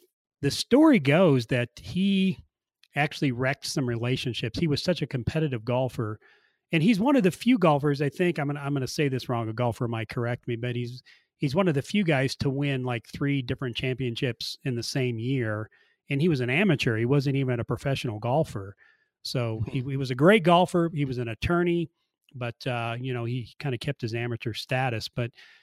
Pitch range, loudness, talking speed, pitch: 120-150 Hz, -26 LUFS, 210 wpm, 135 Hz